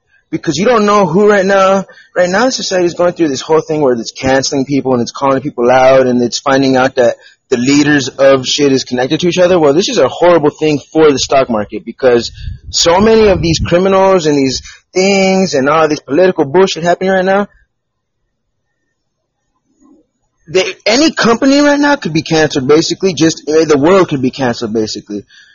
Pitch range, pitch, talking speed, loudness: 135-190 Hz, 160 Hz, 195 wpm, -10 LUFS